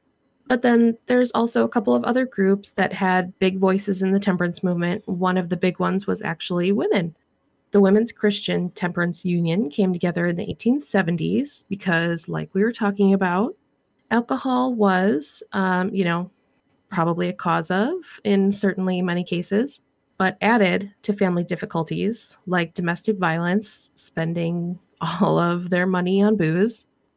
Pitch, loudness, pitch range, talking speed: 190 Hz, -22 LUFS, 175-210 Hz, 150 wpm